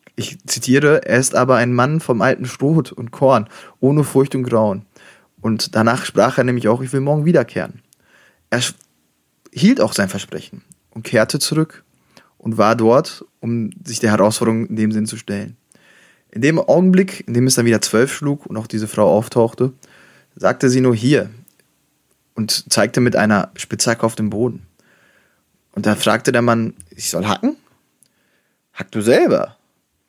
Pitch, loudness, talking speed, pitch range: 120 Hz, -17 LUFS, 170 wpm, 110-135 Hz